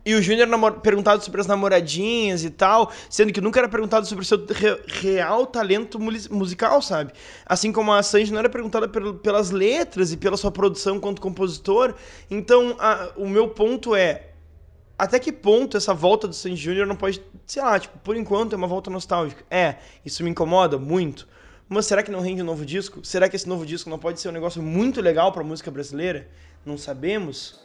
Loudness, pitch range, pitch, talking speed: -22 LUFS, 180-215 Hz, 195 Hz, 210 wpm